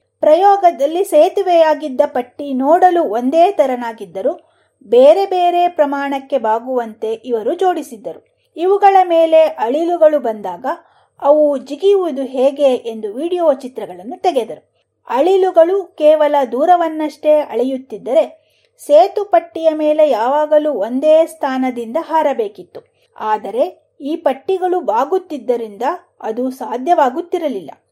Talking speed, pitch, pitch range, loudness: 85 wpm, 305 Hz, 265-350 Hz, -15 LUFS